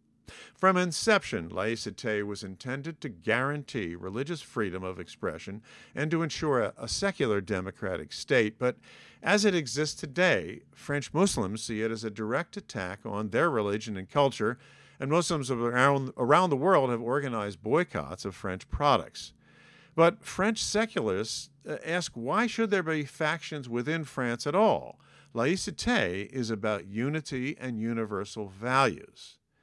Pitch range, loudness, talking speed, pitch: 110-160 Hz, -29 LUFS, 140 wpm, 130 Hz